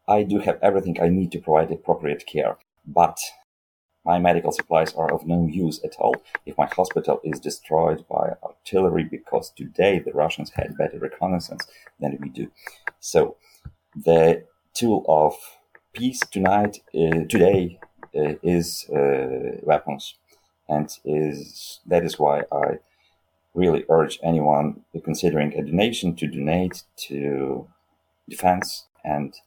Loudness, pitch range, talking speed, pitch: -23 LUFS, 75-90 Hz, 135 wpm, 80 Hz